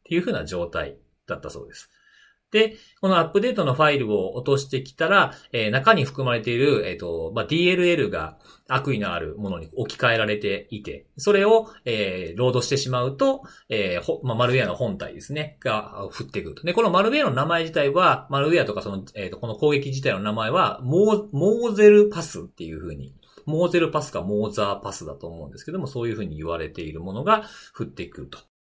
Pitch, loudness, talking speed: 145 Hz, -22 LUFS, 425 characters per minute